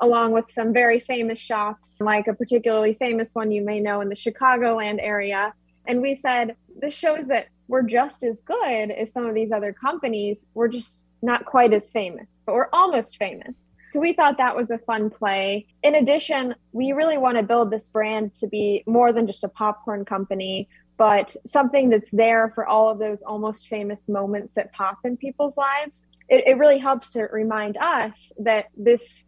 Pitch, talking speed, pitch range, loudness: 225 Hz, 195 wpm, 210-250 Hz, -22 LUFS